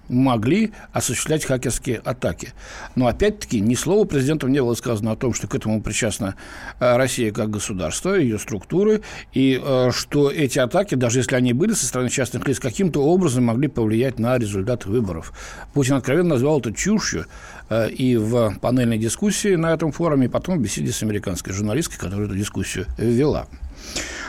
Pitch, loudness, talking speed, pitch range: 125 Hz, -21 LUFS, 160 wpm, 110-140 Hz